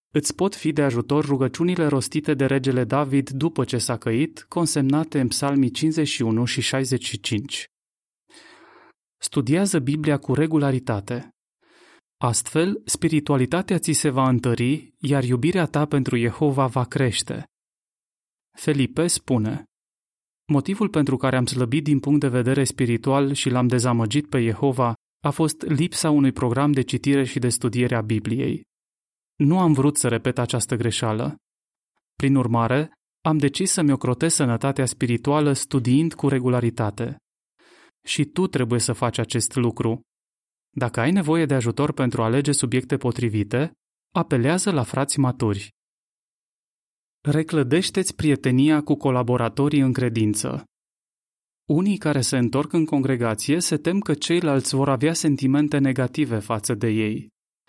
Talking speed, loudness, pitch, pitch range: 135 wpm, -22 LUFS, 135 Hz, 125-150 Hz